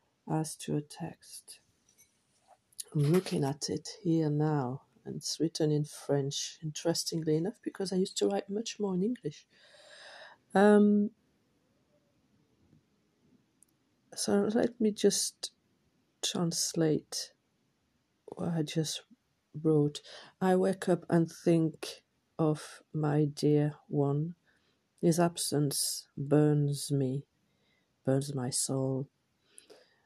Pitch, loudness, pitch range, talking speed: 155 Hz, -31 LUFS, 145-185 Hz, 105 wpm